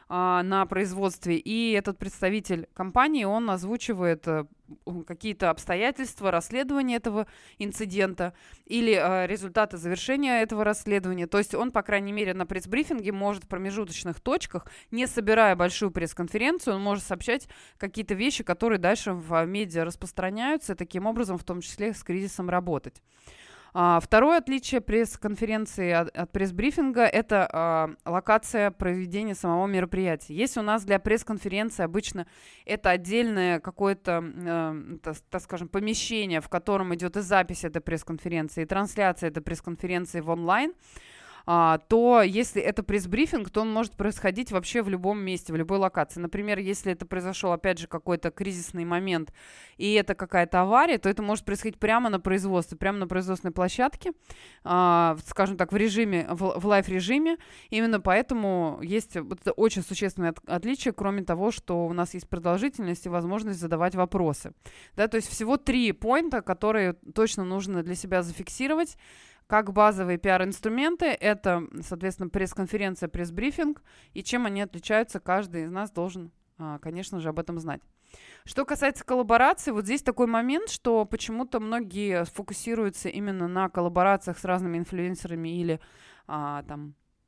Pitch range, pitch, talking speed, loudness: 175-220 Hz, 195 Hz, 145 wpm, -27 LUFS